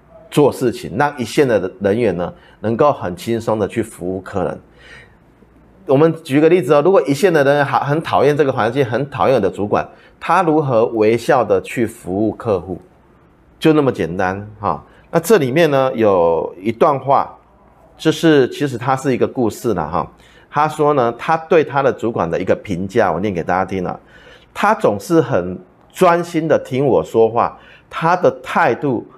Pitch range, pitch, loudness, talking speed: 115-165 Hz, 150 Hz, -16 LUFS, 260 characters per minute